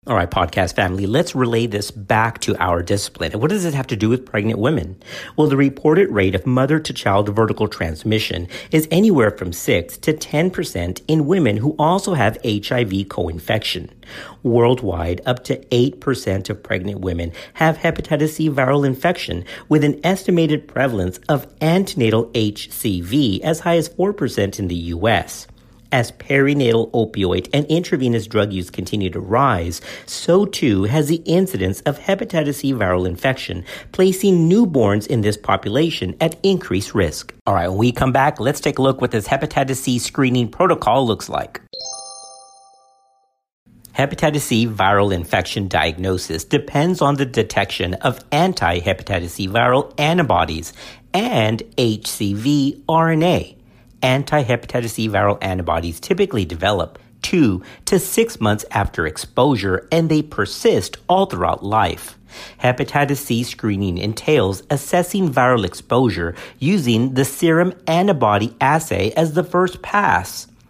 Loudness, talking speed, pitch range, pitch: -18 LUFS, 140 wpm, 100-150 Hz, 125 Hz